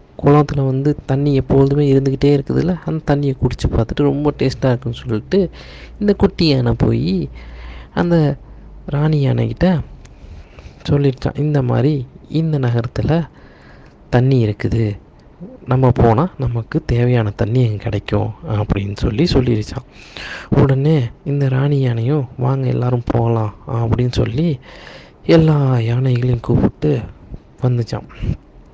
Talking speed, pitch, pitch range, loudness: 105 wpm, 130 Hz, 115-145 Hz, -17 LUFS